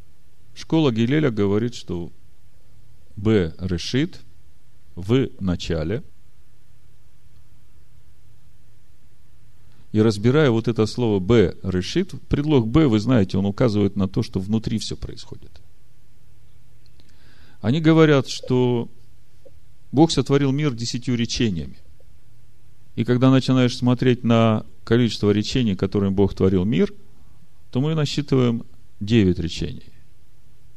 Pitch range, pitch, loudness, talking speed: 100-130 Hz, 115 Hz, -21 LUFS, 100 wpm